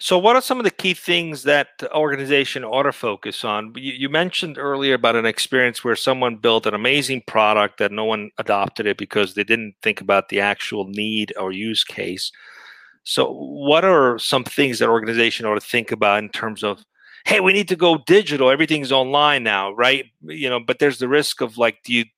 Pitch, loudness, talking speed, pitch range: 130 Hz, -19 LUFS, 205 wpm, 110-150 Hz